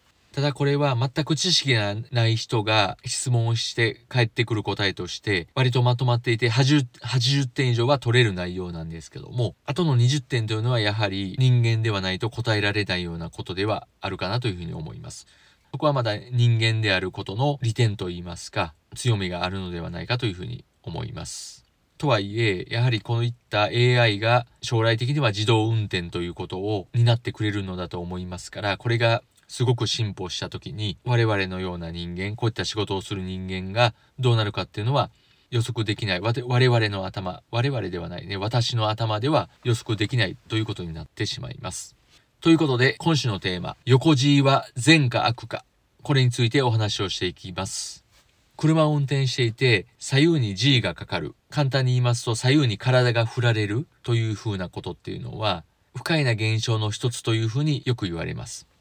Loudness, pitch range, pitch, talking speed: -24 LUFS, 100-125 Hz, 115 Hz, 390 characters per minute